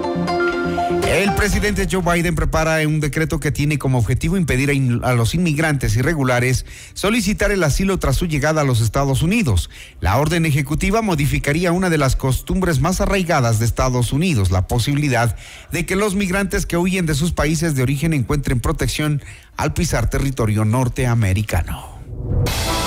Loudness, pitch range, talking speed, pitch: -18 LUFS, 120-170 Hz, 155 wpm, 145 Hz